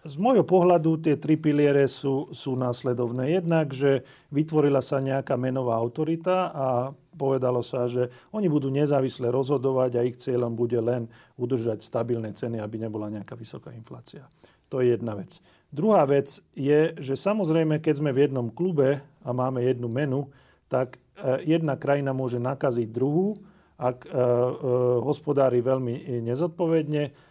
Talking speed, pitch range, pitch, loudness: 145 wpm, 125-150 Hz, 135 Hz, -25 LUFS